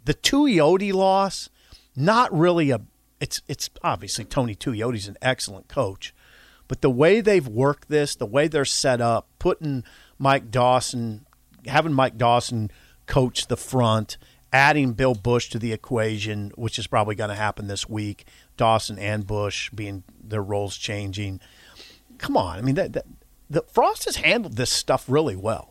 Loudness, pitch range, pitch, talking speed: -23 LUFS, 105-140 Hz, 120 Hz, 160 wpm